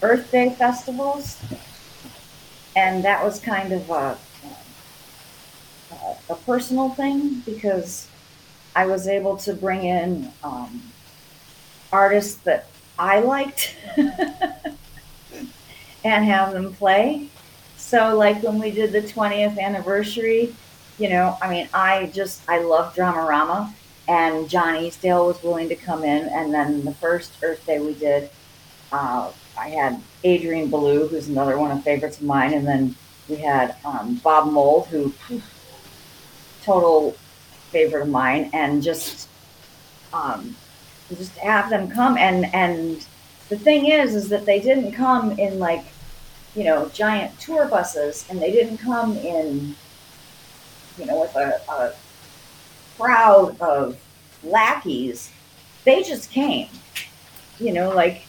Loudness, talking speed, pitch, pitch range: -20 LUFS, 135 wpm, 190 Hz, 160-220 Hz